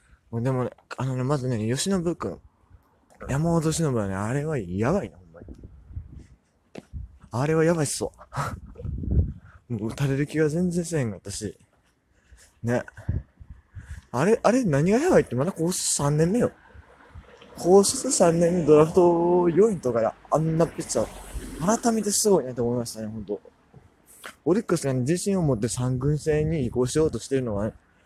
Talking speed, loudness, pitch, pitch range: 310 characters per minute, -24 LUFS, 135 Hz, 105-170 Hz